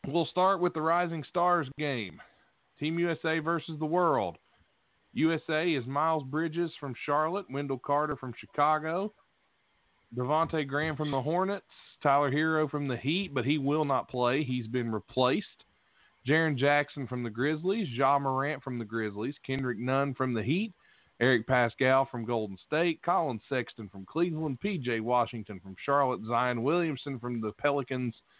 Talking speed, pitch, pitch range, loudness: 155 wpm, 140 Hz, 125-160 Hz, -30 LUFS